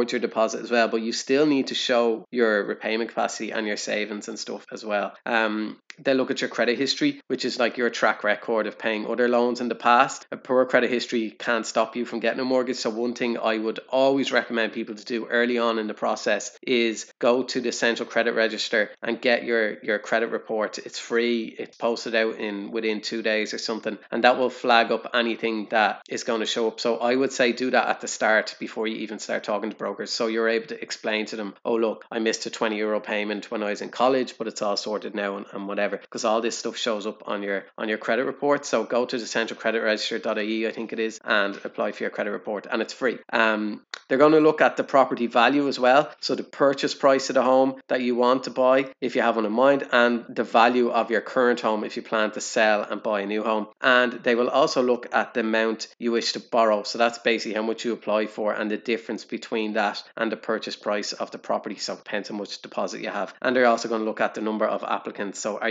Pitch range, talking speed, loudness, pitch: 110-125 Hz, 250 wpm, -24 LUFS, 115 Hz